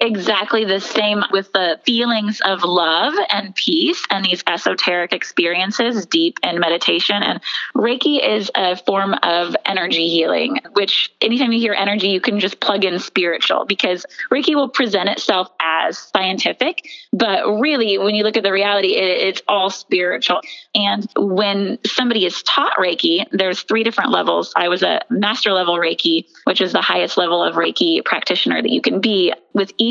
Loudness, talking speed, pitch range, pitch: -17 LUFS, 170 wpm, 190-235 Hz, 205 Hz